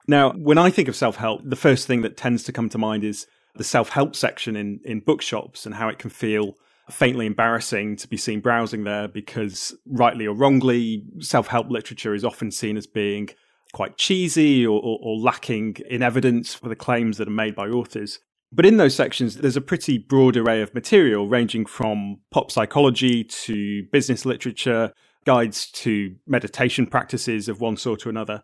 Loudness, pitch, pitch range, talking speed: -21 LUFS, 115 Hz, 110-125 Hz, 190 wpm